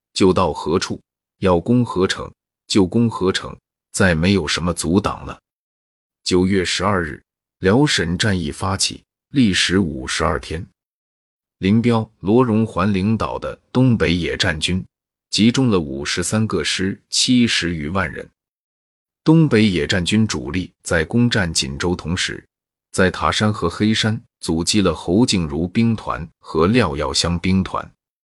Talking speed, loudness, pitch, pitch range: 205 characters per minute, -18 LUFS, 95 Hz, 85-110 Hz